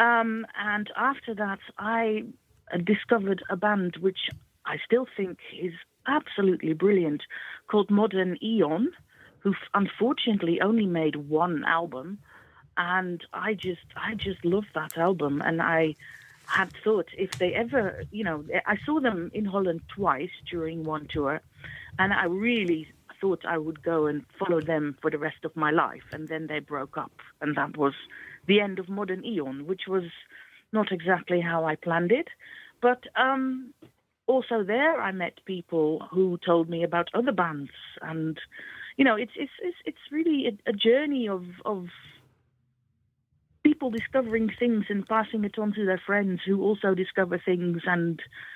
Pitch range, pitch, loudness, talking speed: 165-215 Hz, 185 Hz, -27 LUFS, 160 wpm